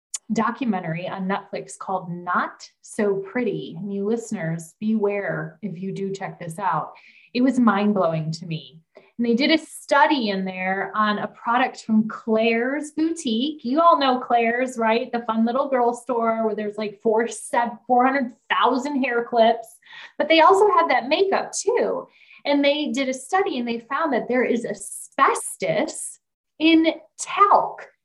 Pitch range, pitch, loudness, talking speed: 205-275 Hz, 235 Hz, -22 LUFS, 160 wpm